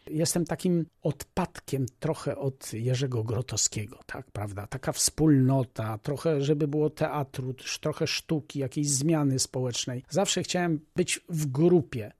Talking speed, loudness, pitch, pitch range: 125 wpm, -28 LUFS, 145 Hz, 130-160 Hz